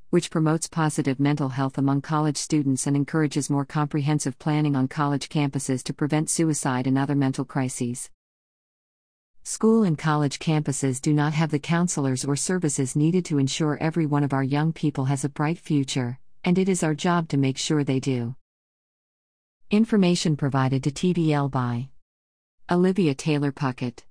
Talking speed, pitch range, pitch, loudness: 160 wpm, 135-155 Hz, 145 Hz, -24 LUFS